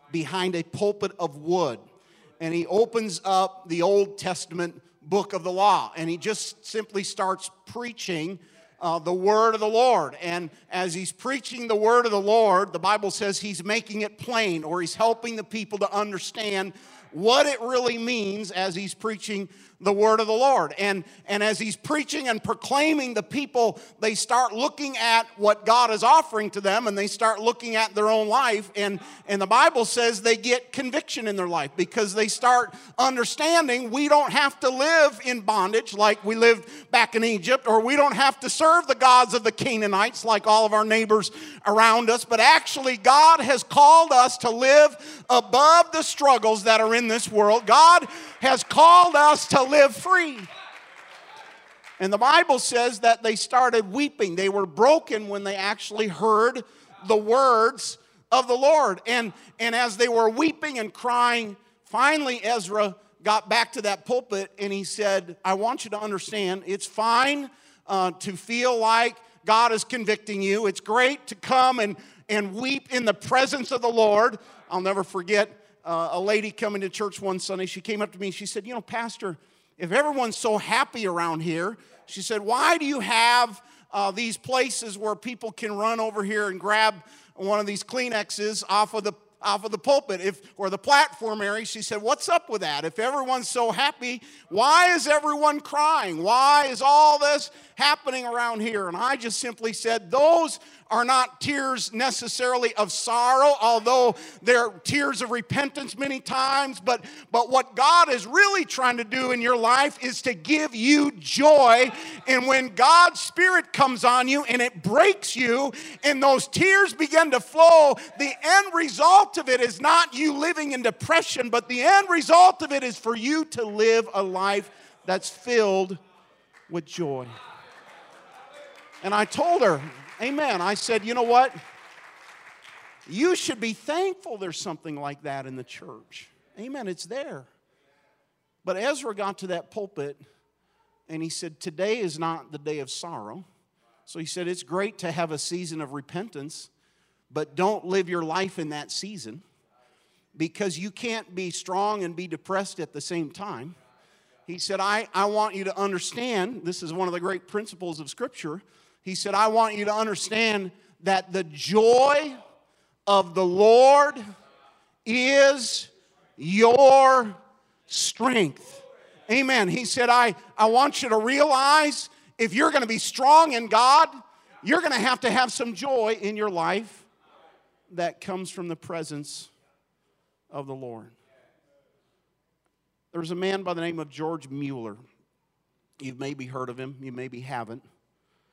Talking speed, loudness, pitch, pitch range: 175 wpm, -22 LUFS, 220 Hz, 195-255 Hz